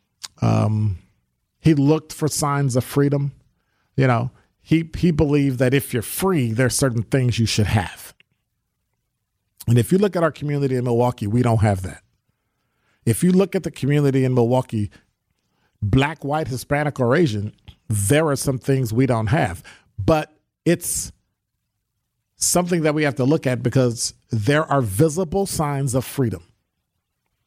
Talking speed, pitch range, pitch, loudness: 155 wpm, 110-145 Hz, 125 Hz, -20 LUFS